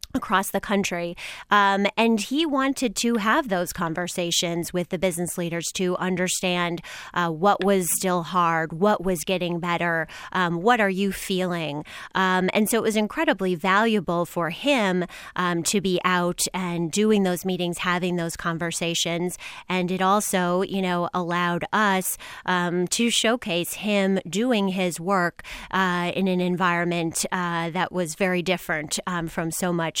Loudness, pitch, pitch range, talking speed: -23 LUFS, 180 Hz, 175-195 Hz, 155 wpm